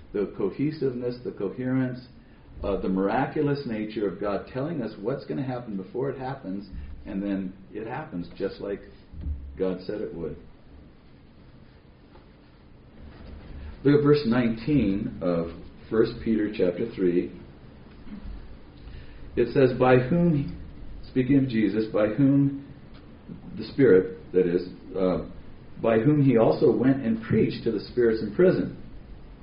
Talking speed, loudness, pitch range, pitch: 135 wpm, -25 LUFS, 80-125 Hz, 100 Hz